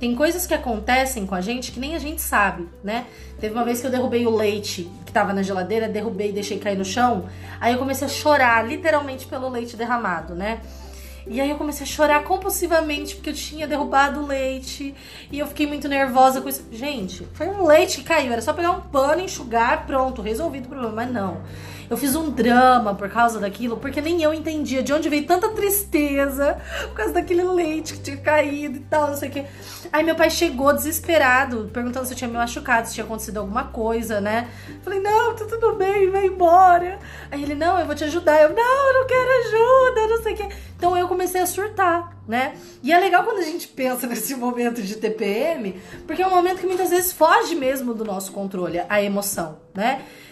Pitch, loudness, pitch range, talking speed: 280 Hz, -21 LUFS, 235-335 Hz, 215 wpm